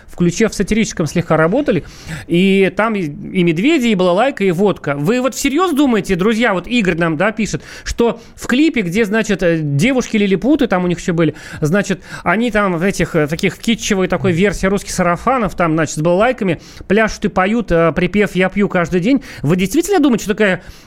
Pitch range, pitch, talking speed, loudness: 170-225 Hz, 190 Hz, 185 wpm, -15 LUFS